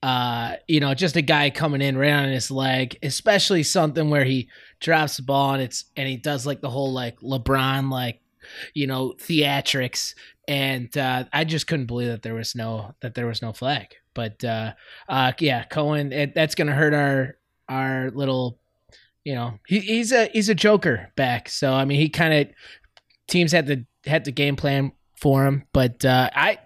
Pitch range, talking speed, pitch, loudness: 125-150 Hz, 200 wpm, 135 Hz, -22 LUFS